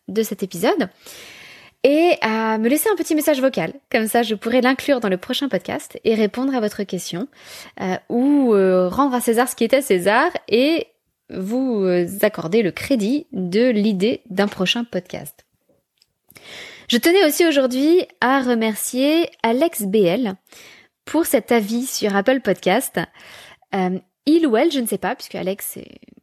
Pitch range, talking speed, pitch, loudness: 200-270 Hz, 160 wpm, 235 Hz, -19 LUFS